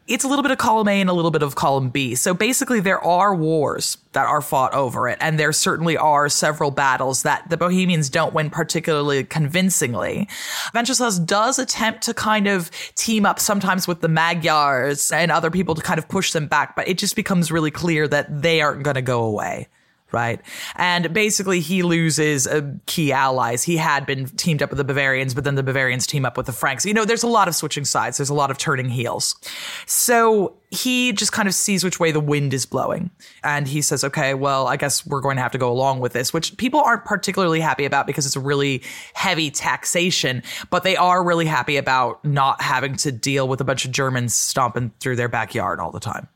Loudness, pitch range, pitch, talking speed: -19 LUFS, 140-190 Hz, 155 Hz, 220 wpm